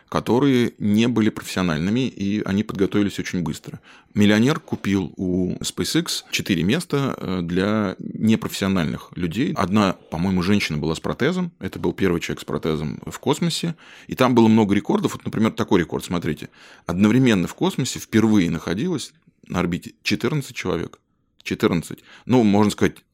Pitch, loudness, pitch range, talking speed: 105 Hz, -21 LUFS, 95-125 Hz, 145 wpm